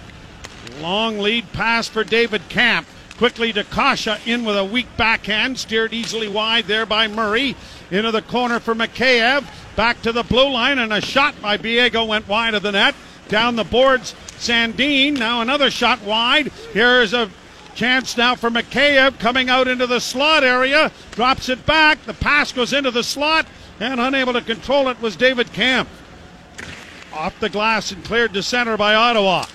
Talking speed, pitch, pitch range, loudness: 175 wpm, 235 Hz, 215-255 Hz, -17 LUFS